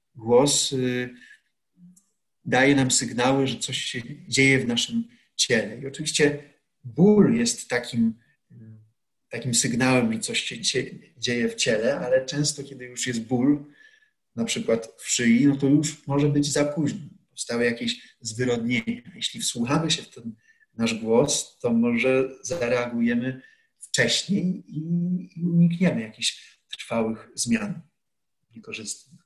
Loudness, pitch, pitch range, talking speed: -24 LUFS, 140 Hz, 120-175 Hz, 130 wpm